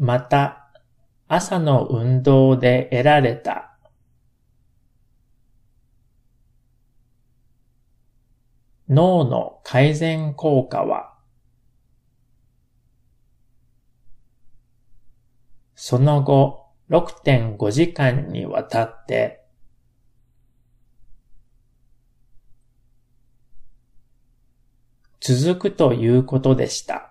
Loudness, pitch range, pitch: -19 LUFS, 120-140 Hz, 125 Hz